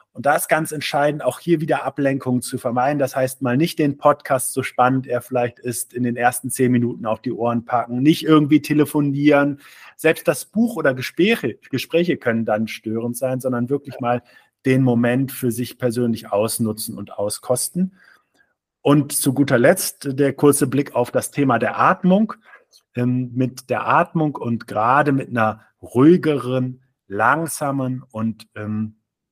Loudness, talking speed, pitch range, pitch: -20 LUFS, 160 wpm, 120-145 Hz, 130 Hz